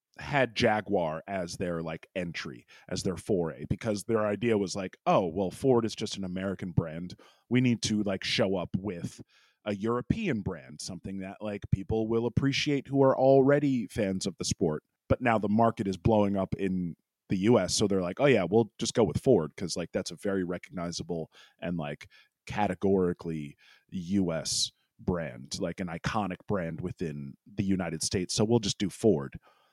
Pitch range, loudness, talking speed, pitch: 90-115 Hz, -29 LUFS, 180 wpm, 100 Hz